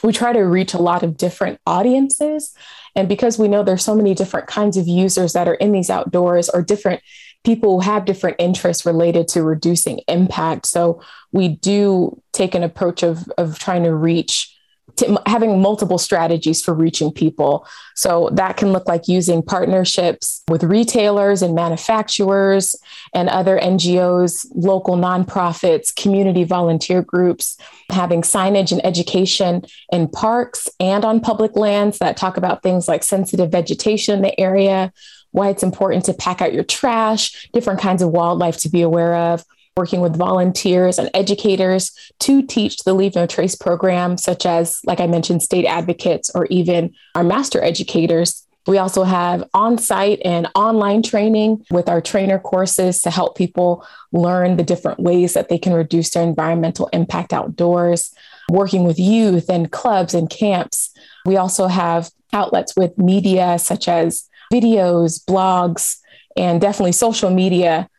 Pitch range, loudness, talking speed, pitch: 175-200 Hz, -16 LUFS, 160 wpm, 185 Hz